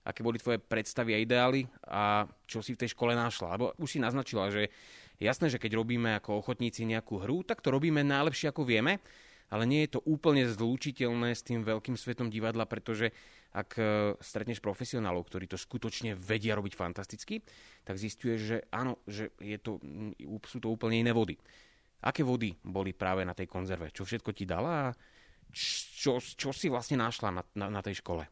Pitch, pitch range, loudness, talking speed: 115 Hz, 105-125 Hz, -33 LUFS, 185 wpm